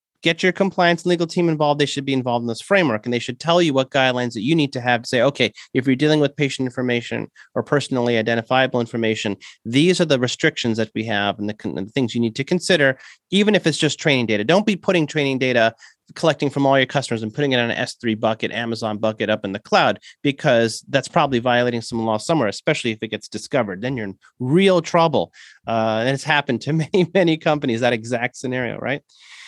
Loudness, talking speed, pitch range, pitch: -20 LUFS, 230 wpm, 115-150 Hz, 130 Hz